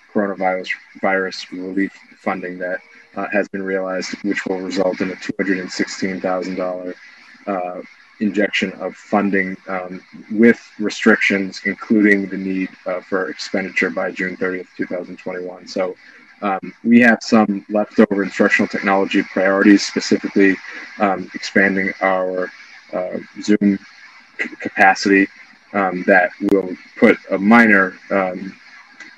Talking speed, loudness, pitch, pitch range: 115 wpm, -18 LUFS, 95 Hz, 95-100 Hz